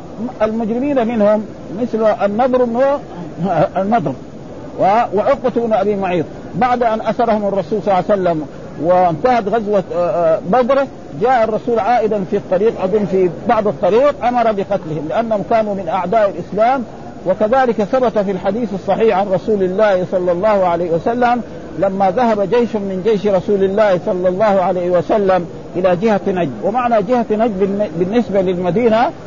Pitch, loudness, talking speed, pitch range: 210 Hz, -15 LUFS, 135 wpm, 185-230 Hz